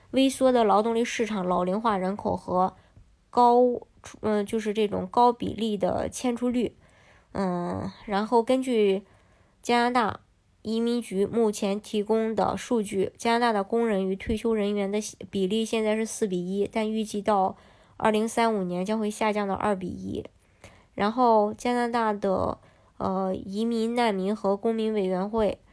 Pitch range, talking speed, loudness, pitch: 200-230 Hz, 235 characters per minute, -26 LUFS, 215 Hz